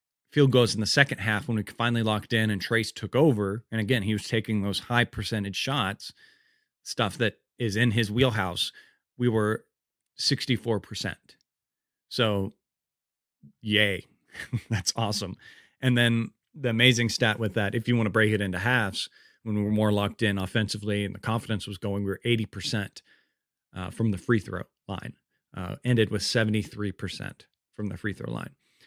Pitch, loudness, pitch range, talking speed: 110 Hz, -27 LUFS, 100-120 Hz, 170 wpm